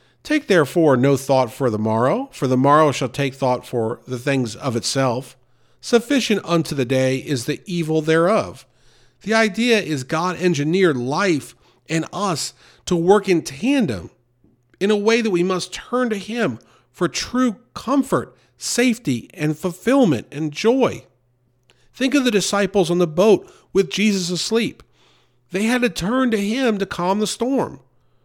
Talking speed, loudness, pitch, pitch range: 160 wpm, -19 LUFS, 175 Hz, 130-215 Hz